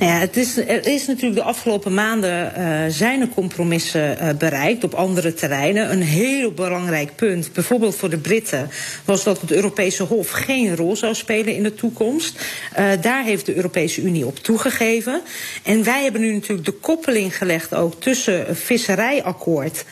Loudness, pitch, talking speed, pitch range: -19 LUFS, 200 Hz, 175 wpm, 175-230 Hz